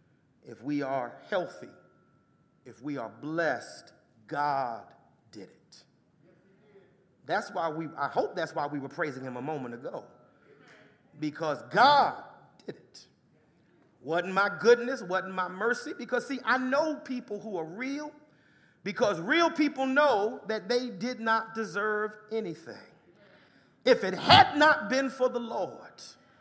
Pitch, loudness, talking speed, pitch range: 200 Hz, -28 LUFS, 140 wpm, 155-250 Hz